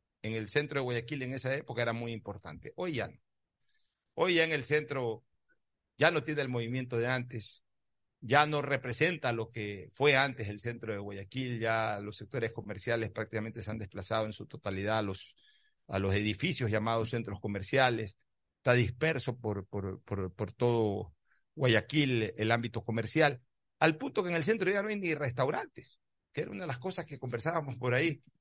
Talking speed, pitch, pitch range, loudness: 185 wpm, 120 Hz, 110-140 Hz, -33 LUFS